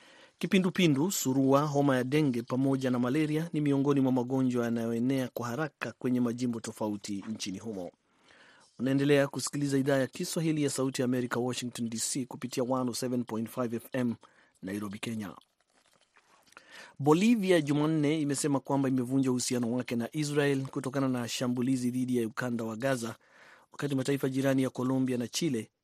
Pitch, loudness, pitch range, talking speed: 130 Hz, -30 LUFS, 120-140 Hz, 135 wpm